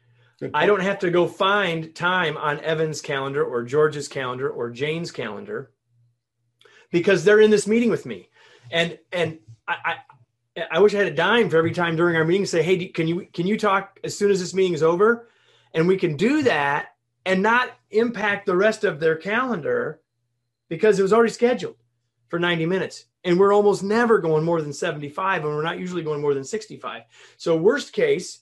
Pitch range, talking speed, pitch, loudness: 150-205 Hz, 205 wpm, 170 Hz, -21 LUFS